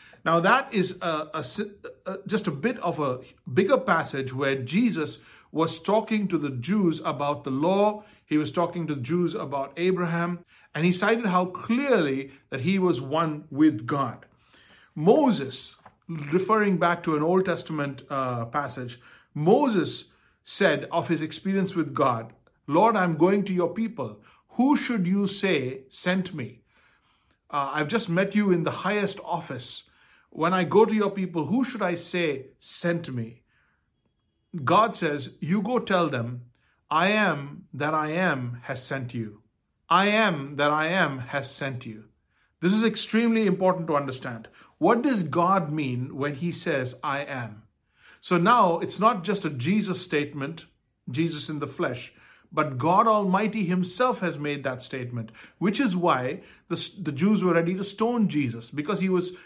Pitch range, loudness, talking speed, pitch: 140-190 Hz, -25 LUFS, 165 wpm, 170 Hz